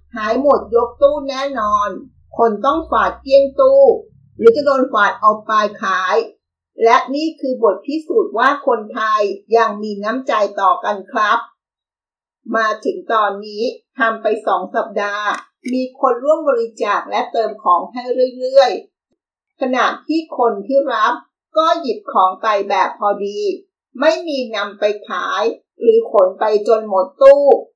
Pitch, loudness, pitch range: 245 Hz, -16 LUFS, 215-285 Hz